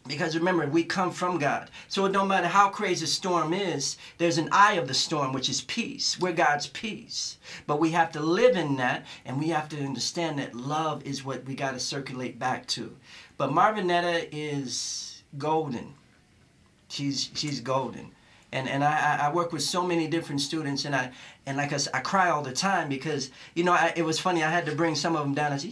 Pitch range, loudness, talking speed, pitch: 135-175 Hz, -27 LUFS, 210 wpm, 150 Hz